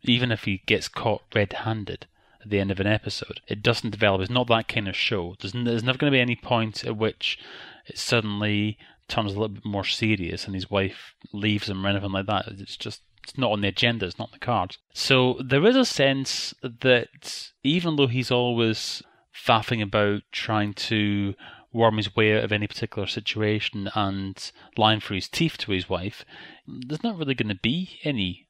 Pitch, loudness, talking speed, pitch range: 110 Hz, -25 LUFS, 205 wpm, 100-120 Hz